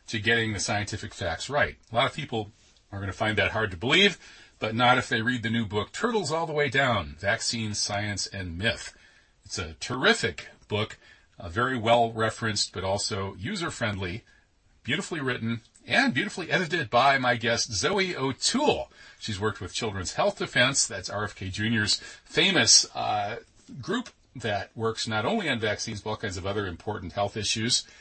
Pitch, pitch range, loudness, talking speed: 110 Hz, 100-120 Hz, -26 LUFS, 180 wpm